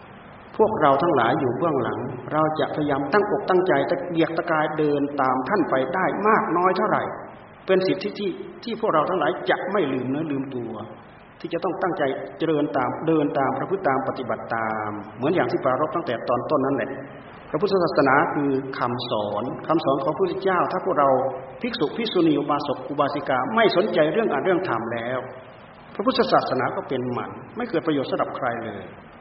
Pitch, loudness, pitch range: 140 Hz, -23 LUFS, 130-170 Hz